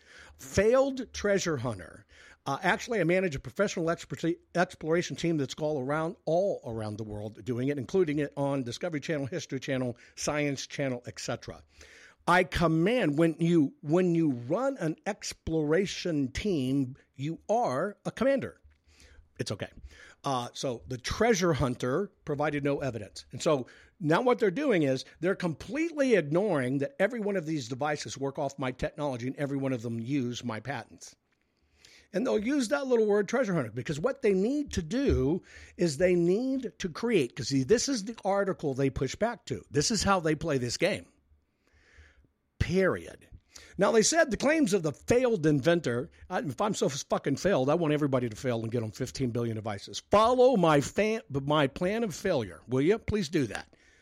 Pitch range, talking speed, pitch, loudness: 130-190 Hz, 175 wpm, 150 Hz, -29 LUFS